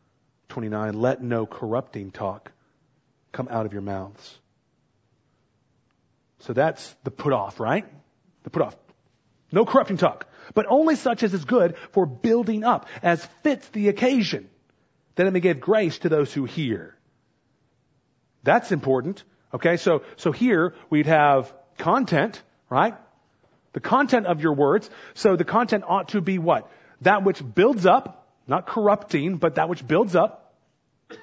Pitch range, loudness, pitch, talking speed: 130-205 Hz, -23 LUFS, 165 Hz, 150 wpm